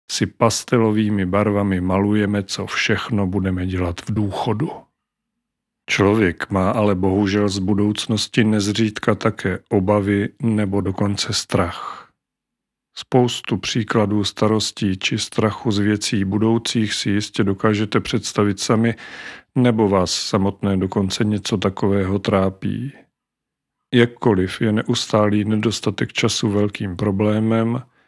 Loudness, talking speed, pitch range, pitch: -19 LUFS, 105 wpm, 100-115 Hz, 105 Hz